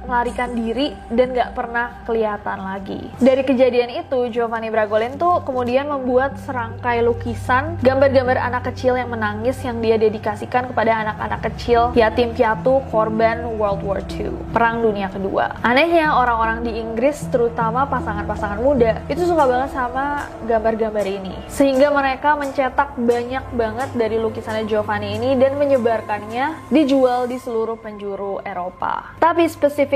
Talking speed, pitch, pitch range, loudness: 135 wpm, 240 Hz, 225-270 Hz, -19 LUFS